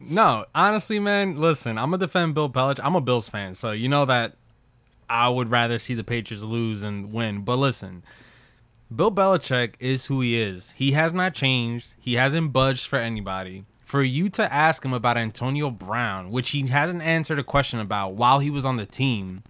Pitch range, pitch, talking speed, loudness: 115-145 Hz, 125 Hz, 200 wpm, -23 LUFS